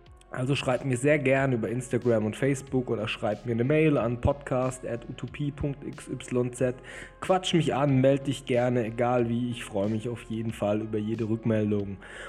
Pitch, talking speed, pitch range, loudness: 125 Hz, 165 wpm, 115-135 Hz, -27 LUFS